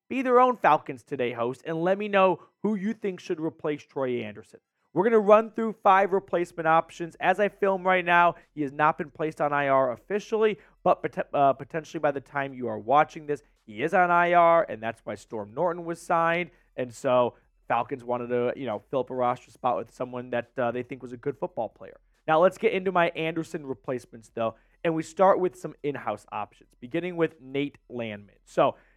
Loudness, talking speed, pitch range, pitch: -26 LUFS, 210 wpm, 125-180 Hz, 160 Hz